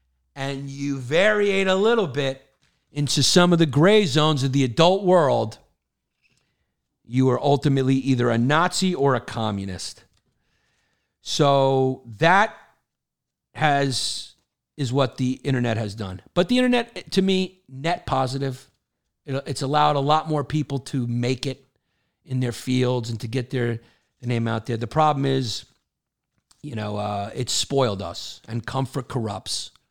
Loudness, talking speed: -22 LUFS, 150 wpm